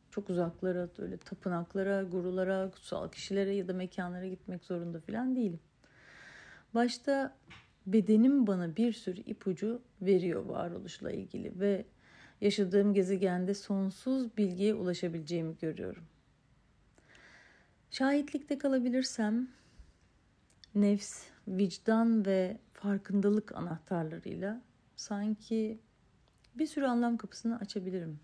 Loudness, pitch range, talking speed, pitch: -34 LUFS, 185-225 Hz, 90 wpm, 200 Hz